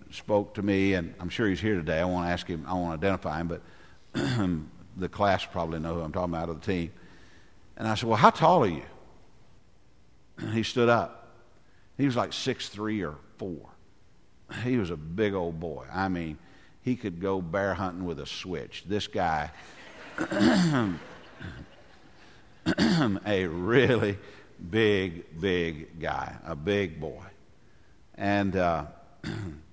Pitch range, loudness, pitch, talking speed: 85-105 Hz, -28 LUFS, 95 Hz, 155 wpm